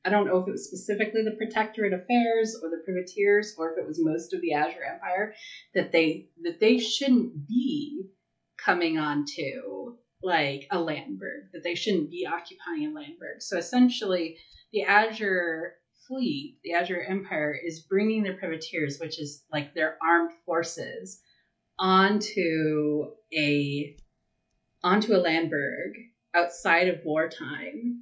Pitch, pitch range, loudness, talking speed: 180 Hz, 165-220 Hz, -27 LUFS, 140 wpm